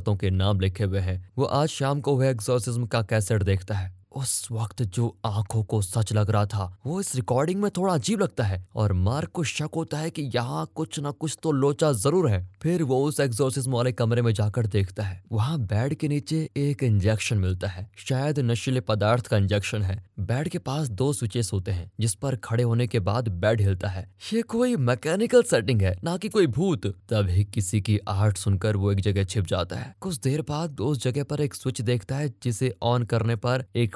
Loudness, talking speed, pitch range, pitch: -26 LUFS, 215 wpm, 105-140 Hz, 120 Hz